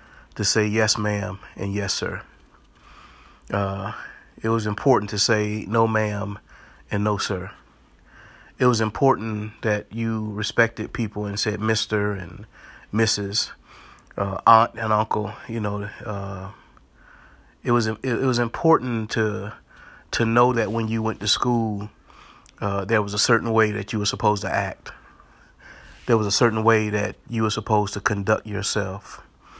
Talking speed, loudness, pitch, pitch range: 150 wpm, -23 LUFS, 105 Hz, 105-115 Hz